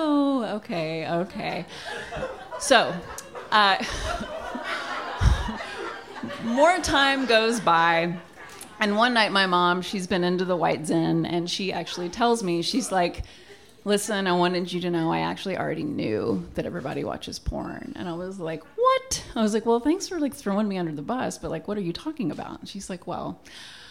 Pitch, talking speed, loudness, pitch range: 195 Hz, 170 wpm, -25 LUFS, 175-230 Hz